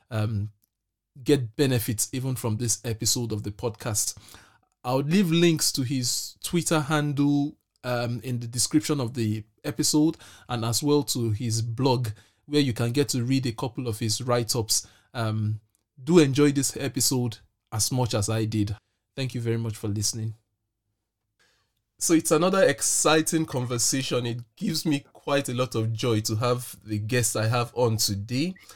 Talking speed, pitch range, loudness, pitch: 165 wpm, 110-135 Hz, -25 LUFS, 120 Hz